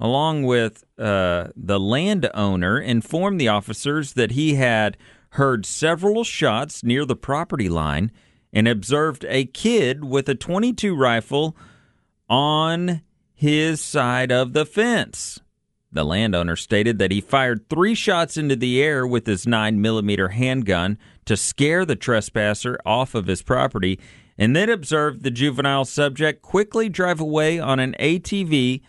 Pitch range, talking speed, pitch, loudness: 110-155 Hz, 140 wpm, 130 Hz, -21 LUFS